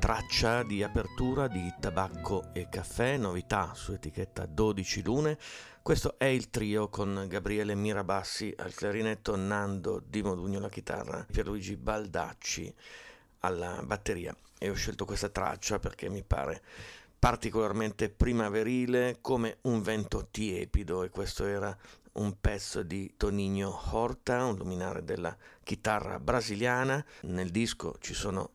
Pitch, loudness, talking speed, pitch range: 105 Hz, -33 LUFS, 130 wpm, 95-115 Hz